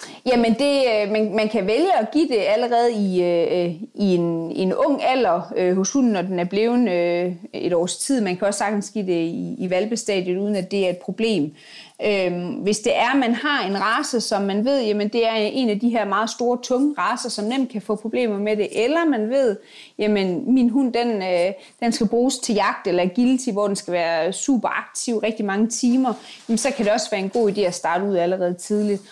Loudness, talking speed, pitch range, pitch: -21 LUFS, 215 wpm, 185-240 Hz, 210 Hz